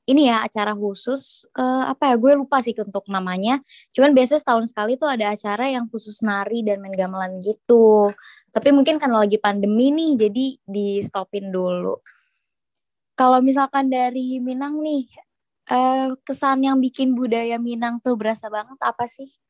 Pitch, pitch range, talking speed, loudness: 245 Hz, 210-270 Hz, 160 wpm, -20 LUFS